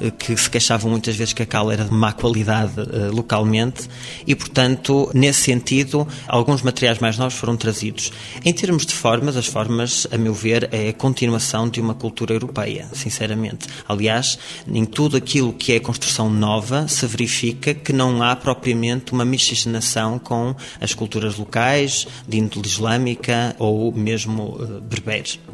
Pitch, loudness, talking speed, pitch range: 120 Hz, -19 LUFS, 155 wpm, 110-130 Hz